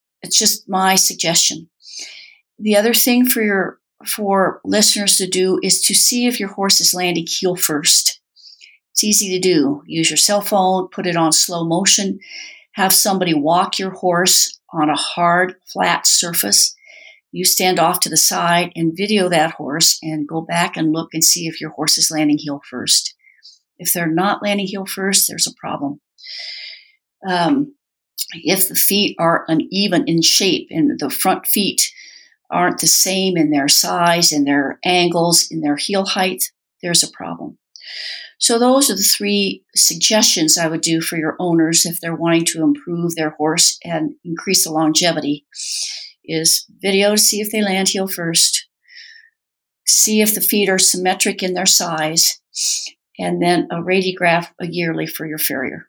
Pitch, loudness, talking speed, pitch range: 185 Hz, -15 LUFS, 170 wpm, 165-205 Hz